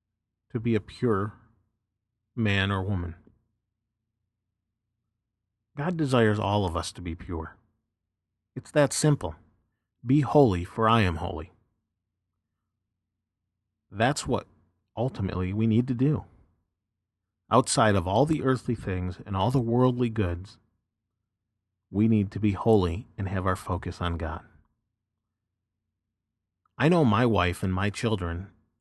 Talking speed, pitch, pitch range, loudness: 125 wpm, 105 Hz, 95-115 Hz, -26 LUFS